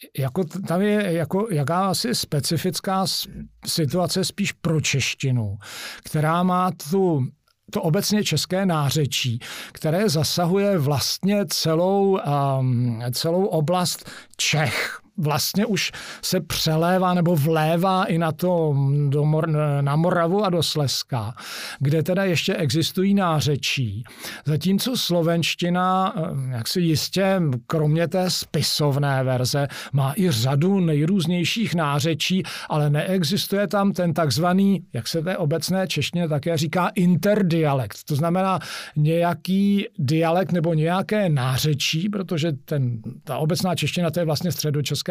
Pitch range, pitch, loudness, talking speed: 145-185 Hz, 165 Hz, -22 LUFS, 120 wpm